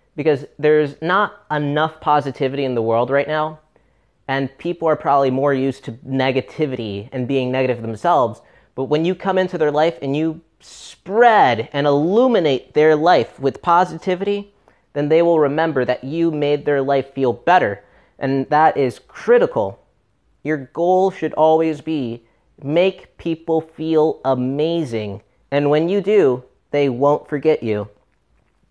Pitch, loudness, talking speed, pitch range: 150 Hz, -18 LUFS, 145 wpm, 135-165 Hz